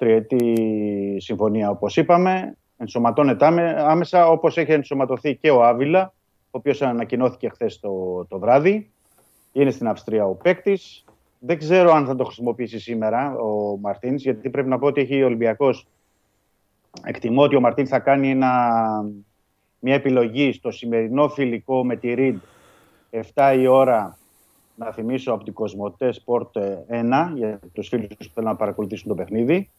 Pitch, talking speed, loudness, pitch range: 125 Hz, 150 wpm, -20 LUFS, 110-140 Hz